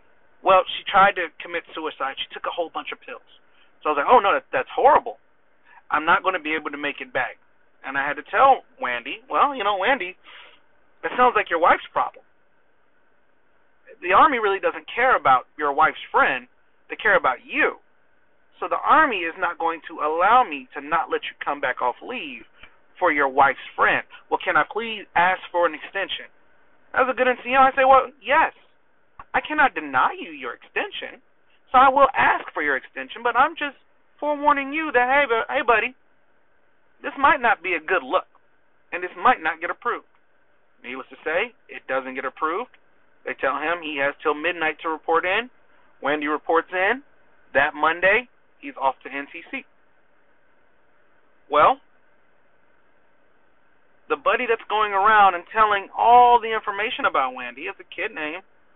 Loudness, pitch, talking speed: -21 LUFS, 240 Hz, 180 wpm